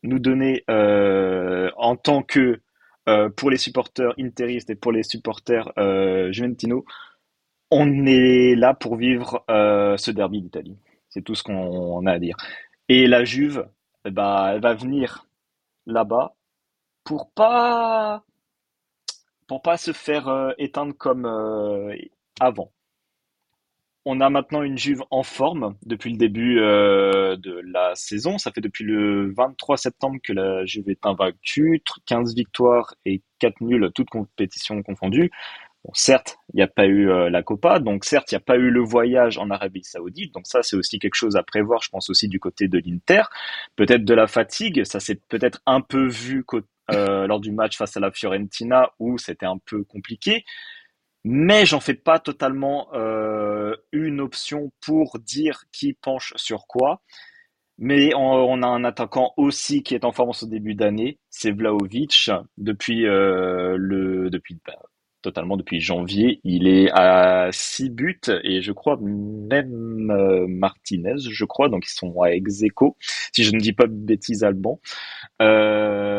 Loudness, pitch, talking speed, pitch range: -20 LUFS, 115 Hz, 165 wpm, 100-130 Hz